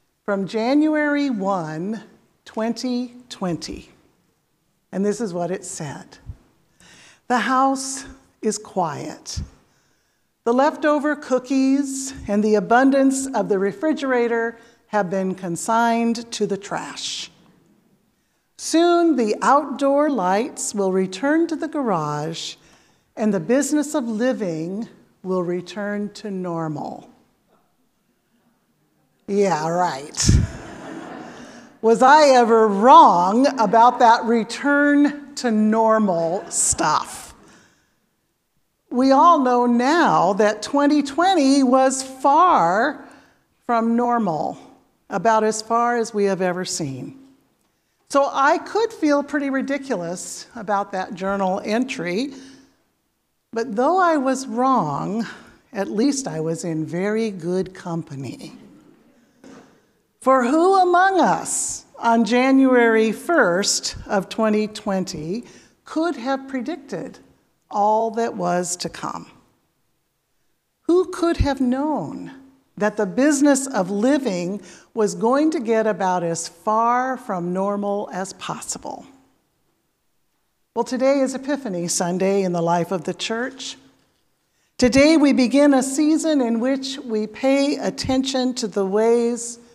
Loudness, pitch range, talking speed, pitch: -20 LUFS, 200-270 Hz, 110 wpm, 235 Hz